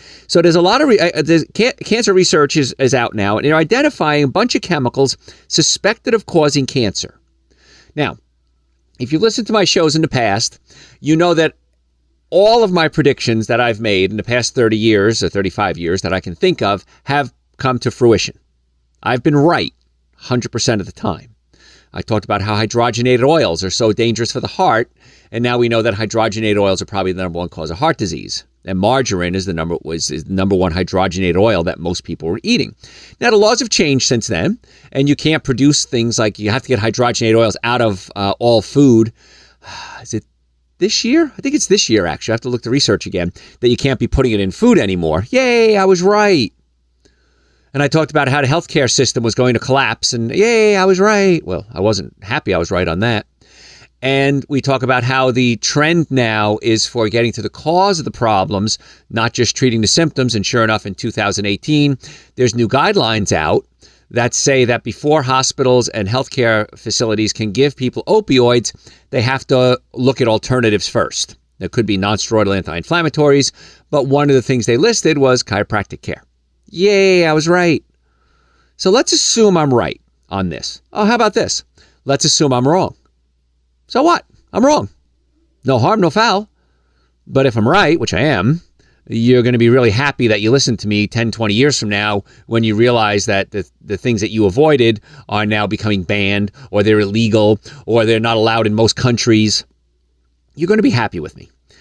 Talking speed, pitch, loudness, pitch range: 200 wpm, 115 Hz, -14 LUFS, 100-140 Hz